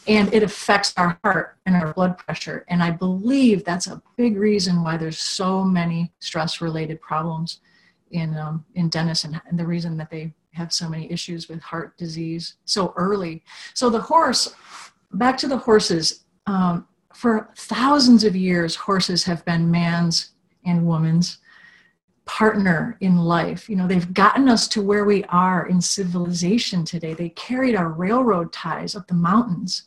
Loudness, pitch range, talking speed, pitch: -21 LUFS, 170-205 Hz, 165 wpm, 180 Hz